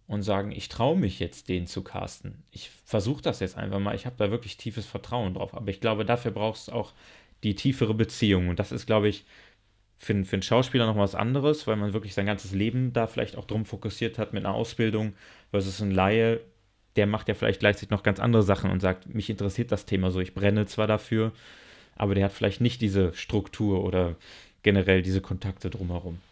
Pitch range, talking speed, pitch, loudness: 95-110 Hz, 220 wpm, 105 Hz, -27 LUFS